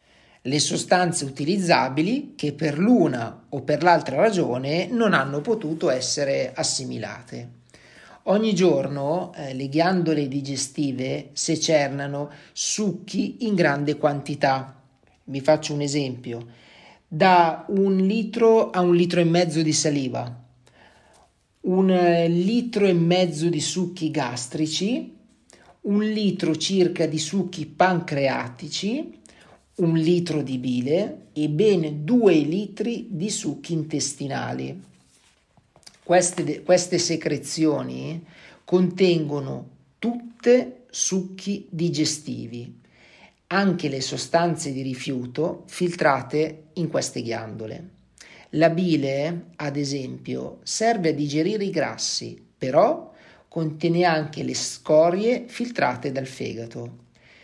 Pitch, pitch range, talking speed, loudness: 160 Hz, 140-180 Hz, 105 wpm, -23 LUFS